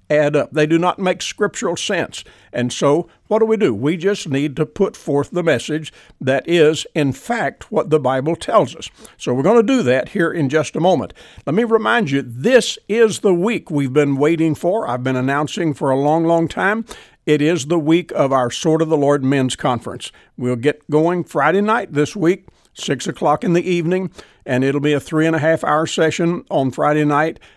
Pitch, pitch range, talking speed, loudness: 155 Hz, 145-175 Hz, 215 wpm, -17 LUFS